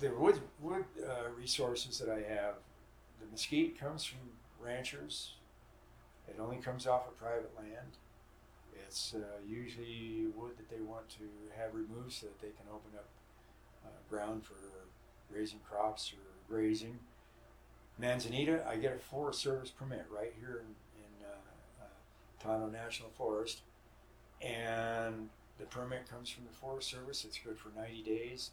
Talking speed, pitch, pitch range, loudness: 150 wpm, 115 Hz, 110-125 Hz, -41 LUFS